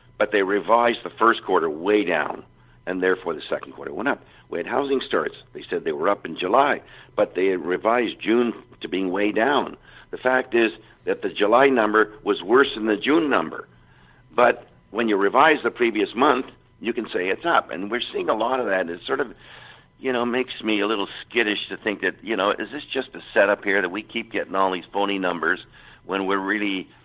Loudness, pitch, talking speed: -22 LUFS, 120 Hz, 215 wpm